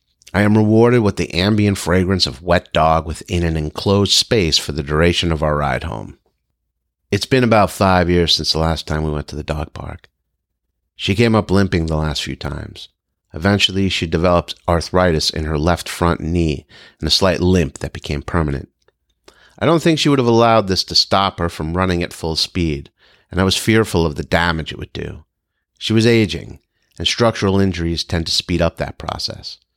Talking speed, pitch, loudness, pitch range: 200 wpm, 85 Hz, -16 LUFS, 80-95 Hz